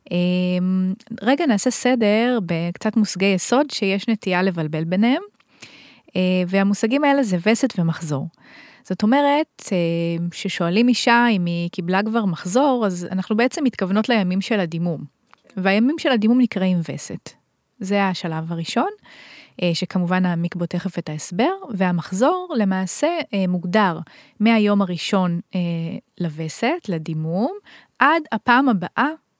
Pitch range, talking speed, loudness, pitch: 175-240 Hz, 110 wpm, -20 LUFS, 195 Hz